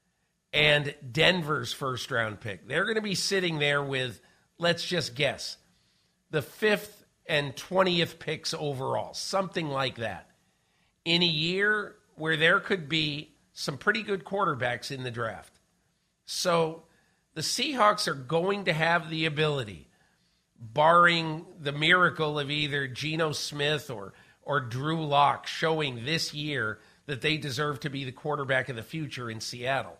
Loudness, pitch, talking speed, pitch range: -27 LUFS, 155 Hz, 145 wpm, 140-170 Hz